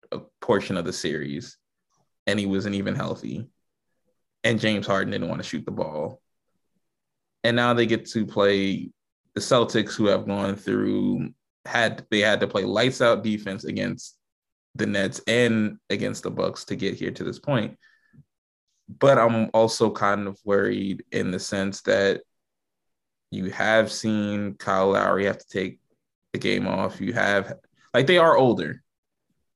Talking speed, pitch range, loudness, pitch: 160 wpm, 100-110 Hz, -24 LUFS, 100 Hz